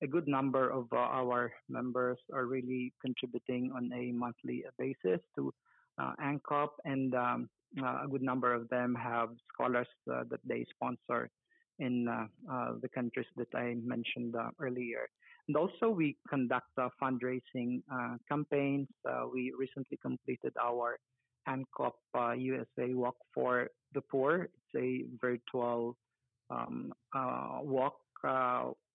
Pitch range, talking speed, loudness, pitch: 120-130 Hz, 145 wpm, -37 LUFS, 125 Hz